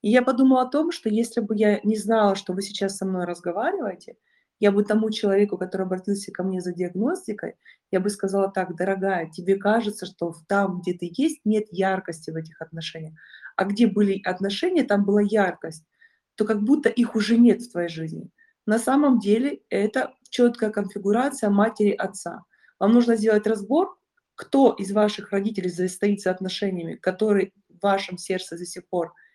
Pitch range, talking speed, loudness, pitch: 185-225 Hz, 175 wpm, -23 LUFS, 205 Hz